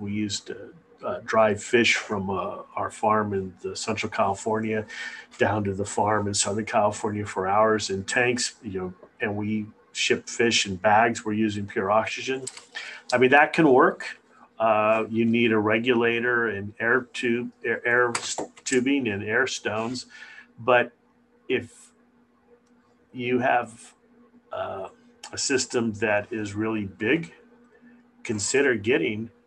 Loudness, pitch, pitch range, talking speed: -24 LUFS, 115 Hz, 105-130 Hz, 140 wpm